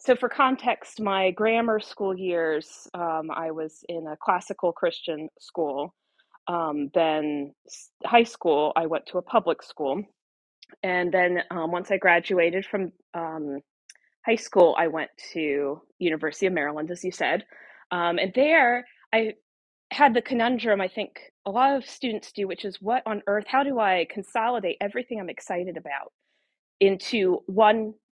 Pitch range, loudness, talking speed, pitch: 165-225 Hz, -25 LUFS, 160 wpm, 190 Hz